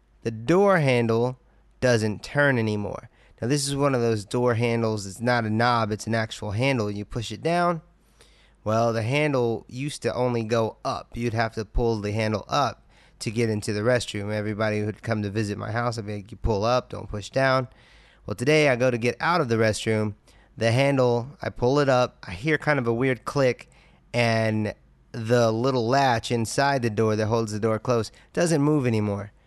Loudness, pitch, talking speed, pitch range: -24 LUFS, 115 Hz, 205 wpm, 110-130 Hz